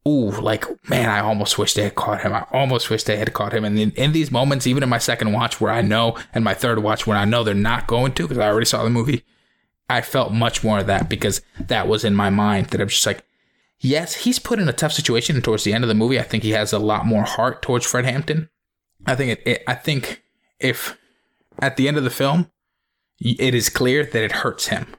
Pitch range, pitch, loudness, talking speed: 105-130 Hz, 115 Hz, -20 LUFS, 260 wpm